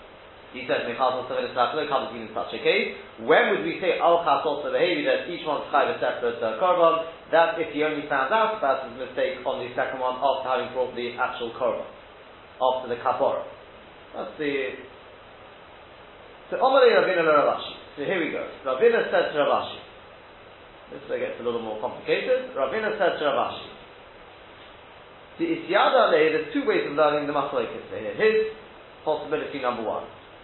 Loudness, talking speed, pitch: -24 LUFS, 170 wpm, 180 Hz